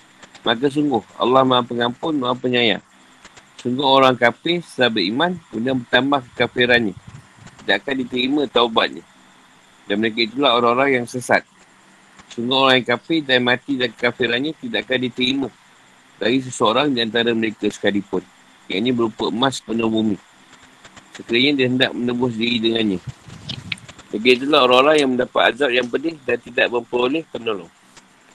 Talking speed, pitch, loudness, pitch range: 140 wpm, 125 Hz, -18 LUFS, 115-130 Hz